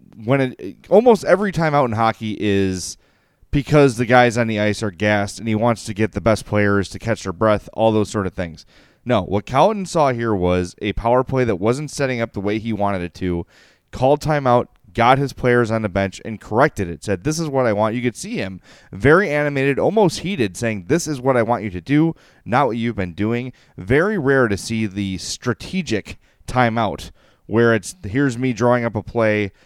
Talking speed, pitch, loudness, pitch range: 215 wpm, 115 Hz, -19 LUFS, 105-135 Hz